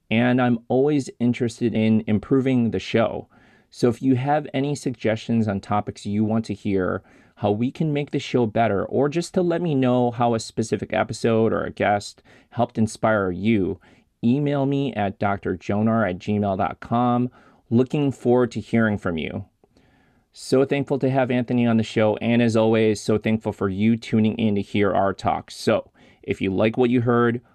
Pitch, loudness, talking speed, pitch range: 115 Hz, -22 LUFS, 180 wpm, 105-125 Hz